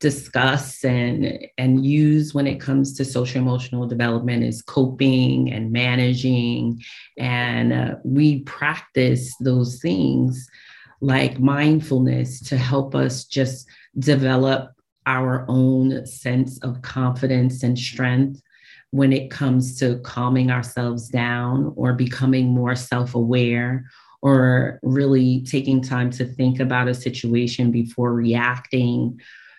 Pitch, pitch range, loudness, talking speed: 130 Hz, 125-135 Hz, -20 LUFS, 115 wpm